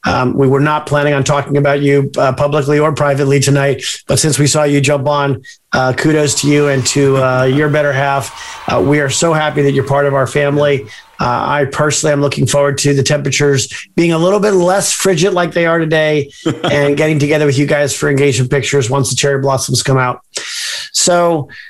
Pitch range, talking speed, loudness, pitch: 140-150 Hz, 215 wpm, -12 LUFS, 145 Hz